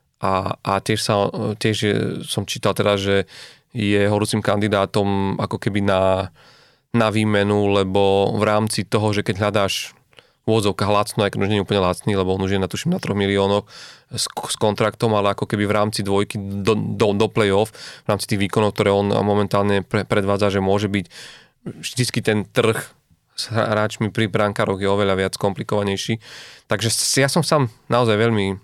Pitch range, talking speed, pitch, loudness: 100-110 Hz, 170 wpm, 105 Hz, -20 LUFS